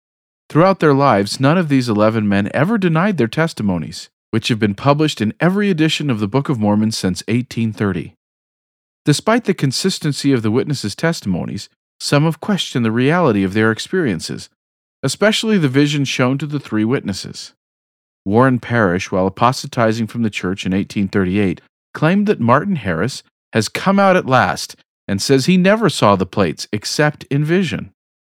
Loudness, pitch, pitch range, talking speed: -16 LUFS, 125 Hz, 105-155 Hz, 165 wpm